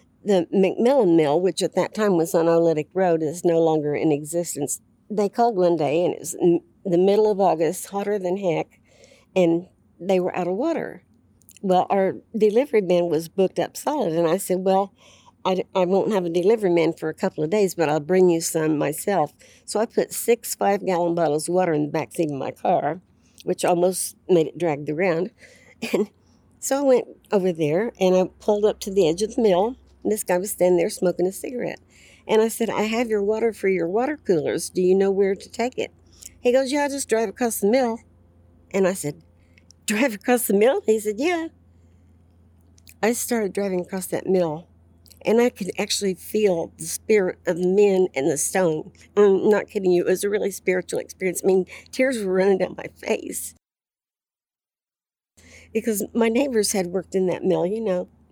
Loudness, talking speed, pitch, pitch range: -22 LUFS, 205 wpm, 185 Hz, 165-210 Hz